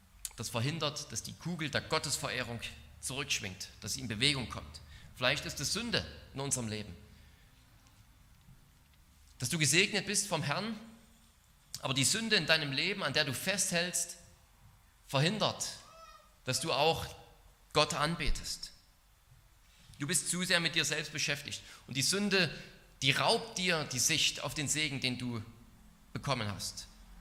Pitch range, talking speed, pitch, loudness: 115-170 Hz, 145 wpm, 145 Hz, -32 LUFS